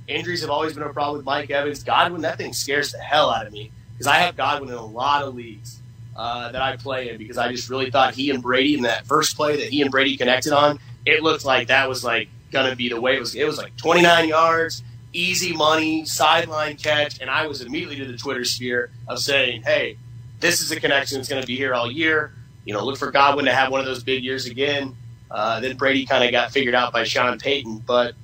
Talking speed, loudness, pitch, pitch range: 250 wpm, -20 LUFS, 135 Hz, 120-145 Hz